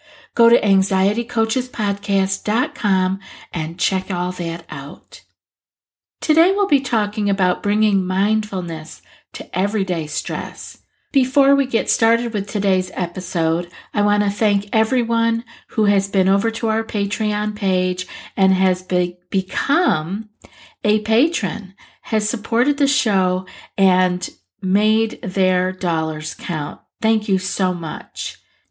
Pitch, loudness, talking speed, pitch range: 200 Hz, -19 LUFS, 120 wpm, 185-225 Hz